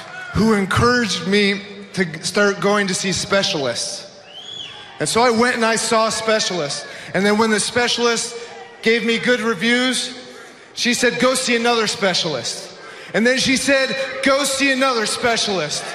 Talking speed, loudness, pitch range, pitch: 150 wpm, -18 LUFS, 200-245 Hz, 225 Hz